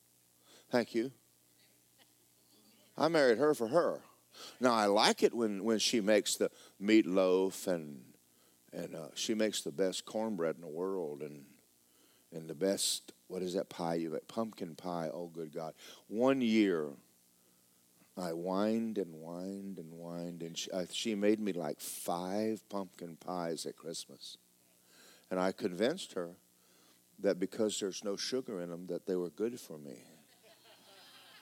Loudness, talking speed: -35 LUFS, 155 wpm